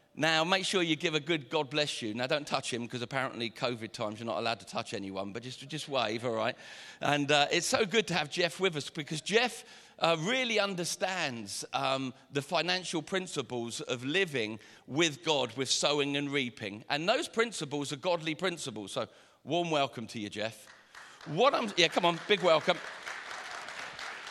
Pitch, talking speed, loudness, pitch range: 150 Hz, 190 wpm, -31 LUFS, 125-175 Hz